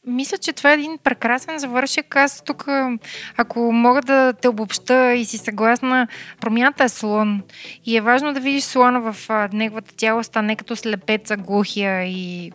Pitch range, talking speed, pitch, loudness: 220-265 Hz, 165 wpm, 240 Hz, -19 LUFS